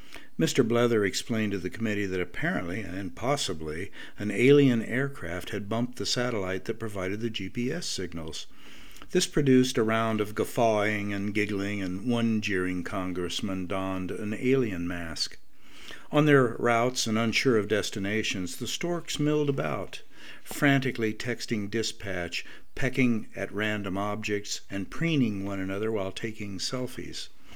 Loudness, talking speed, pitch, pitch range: -28 LUFS, 140 wpm, 110 Hz, 95-125 Hz